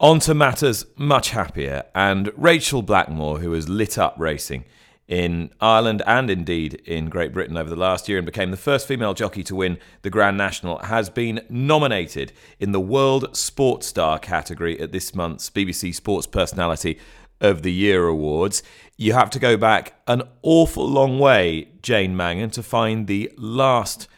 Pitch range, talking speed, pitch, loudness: 85-120 Hz, 170 wpm, 100 Hz, -20 LUFS